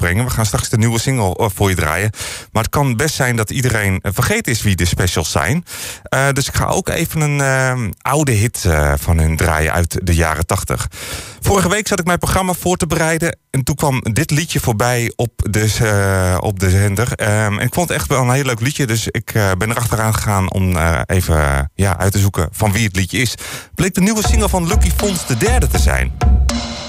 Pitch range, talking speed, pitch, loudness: 95-135 Hz, 220 wpm, 110 Hz, -16 LUFS